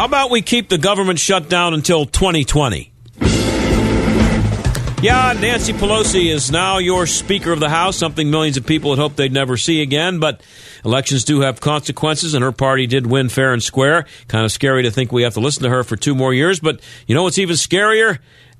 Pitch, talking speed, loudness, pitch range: 150 Hz, 205 wpm, -15 LUFS, 125-180 Hz